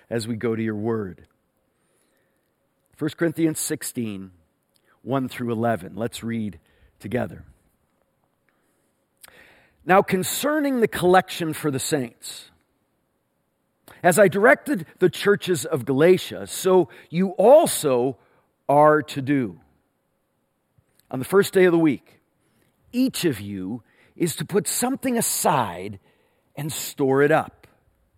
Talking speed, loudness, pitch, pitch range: 115 wpm, -22 LUFS, 140 Hz, 110-180 Hz